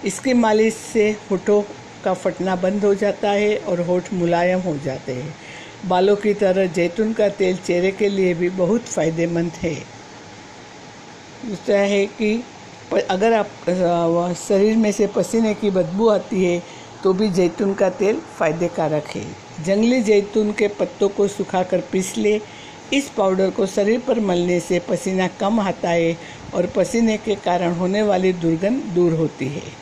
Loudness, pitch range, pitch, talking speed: -20 LUFS, 175-210 Hz, 190 Hz, 160 wpm